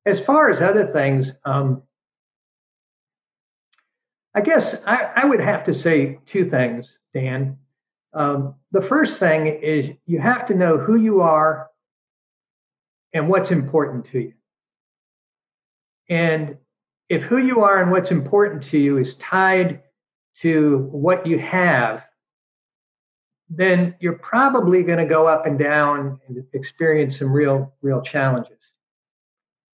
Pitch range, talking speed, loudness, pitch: 140-180 Hz, 130 wpm, -19 LUFS, 155 Hz